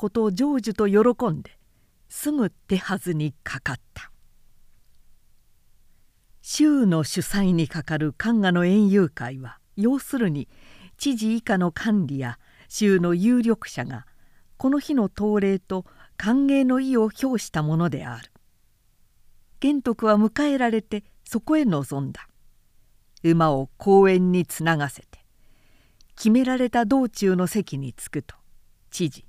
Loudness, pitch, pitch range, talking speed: -23 LUFS, 195 Hz, 150-230 Hz, 225 characters per minute